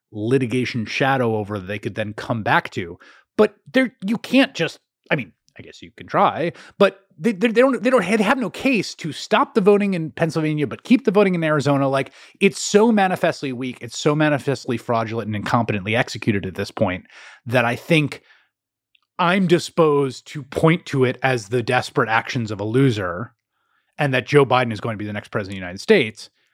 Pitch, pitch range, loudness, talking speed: 135 Hz, 115-190 Hz, -20 LUFS, 205 wpm